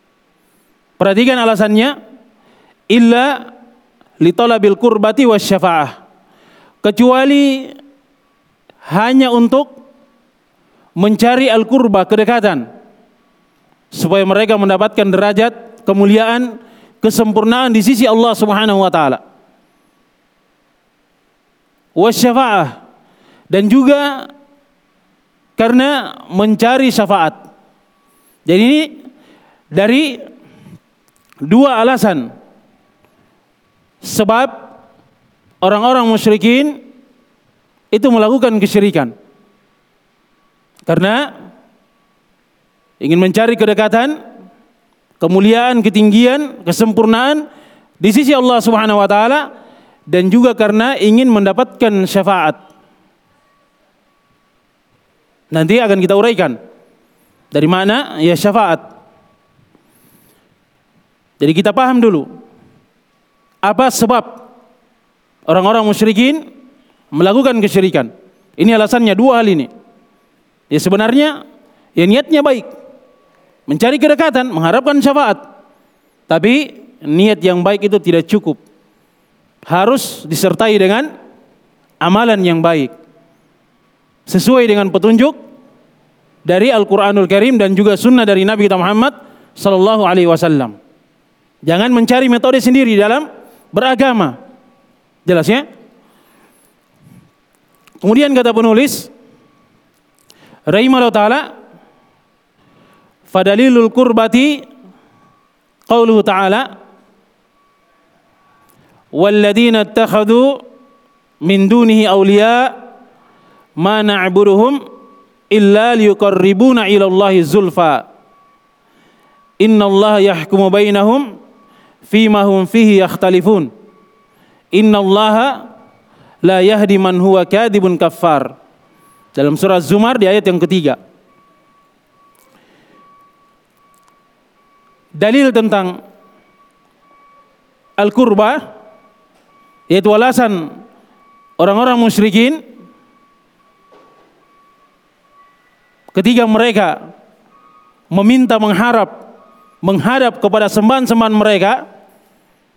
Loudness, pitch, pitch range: -11 LUFS, 225 Hz, 200-260 Hz